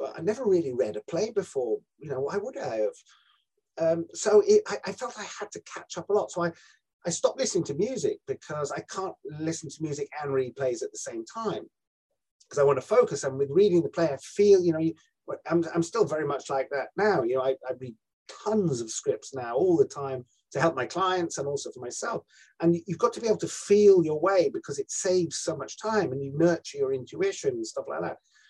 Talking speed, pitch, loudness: 240 wpm, 195 Hz, -27 LUFS